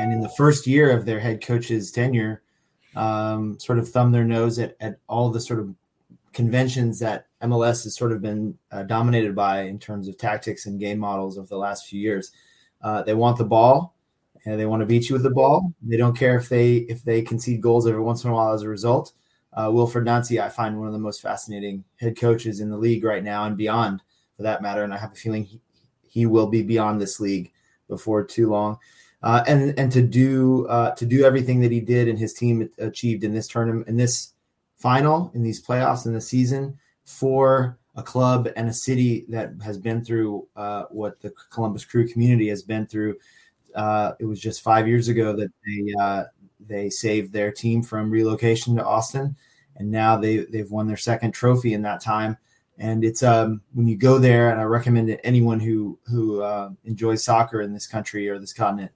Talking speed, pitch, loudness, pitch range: 215 wpm, 115 Hz, -22 LUFS, 105-120 Hz